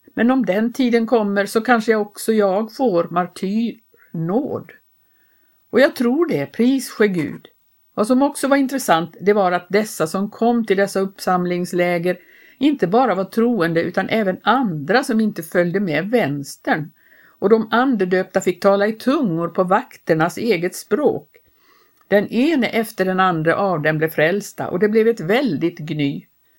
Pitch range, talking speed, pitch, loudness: 180-235 Hz, 160 wpm, 205 Hz, -19 LUFS